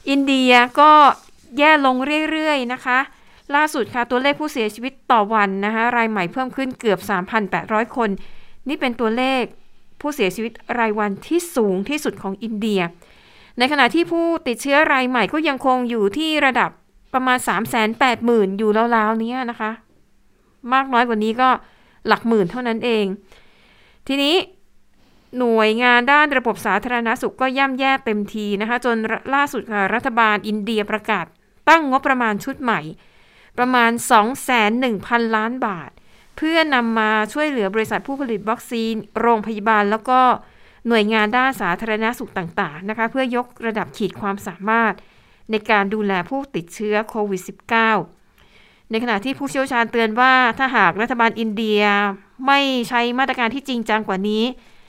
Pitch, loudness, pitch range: 230 Hz, -18 LUFS, 215-260 Hz